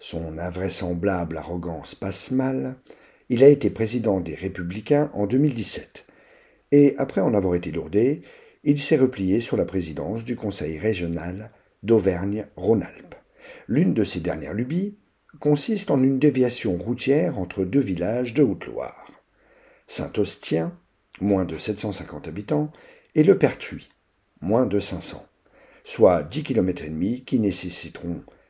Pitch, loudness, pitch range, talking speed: 105 Hz, -23 LUFS, 90-130 Hz, 130 wpm